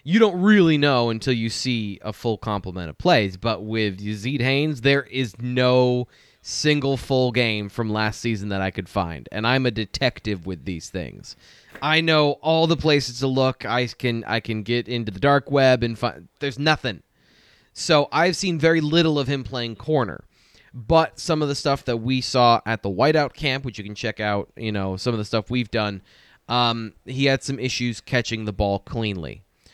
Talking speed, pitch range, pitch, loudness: 200 wpm, 110-140 Hz, 120 Hz, -22 LUFS